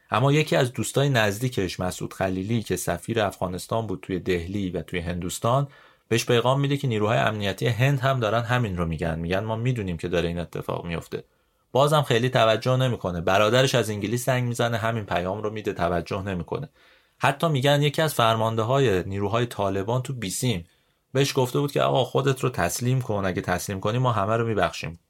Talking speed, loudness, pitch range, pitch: 185 wpm, -24 LUFS, 95-130 Hz, 110 Hz